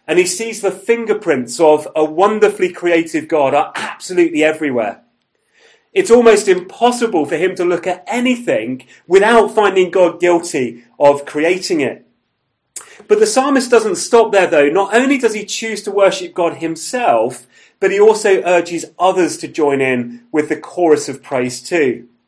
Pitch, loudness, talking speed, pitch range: 185 Hz, -14 LUFS, 160 wpm, 155-230 Hz